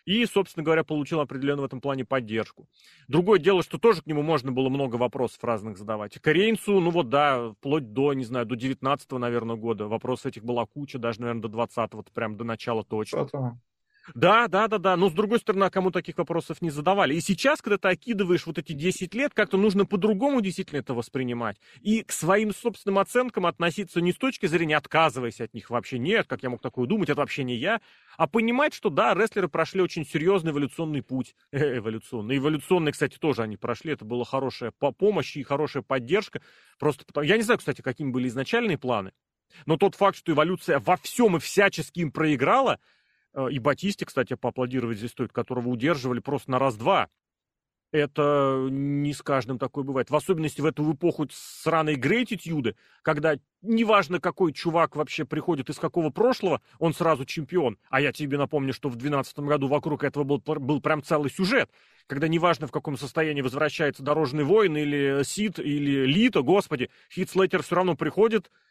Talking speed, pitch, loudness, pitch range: 185 wpm, 150 Hz, -26 LUFS, 130-180 Hz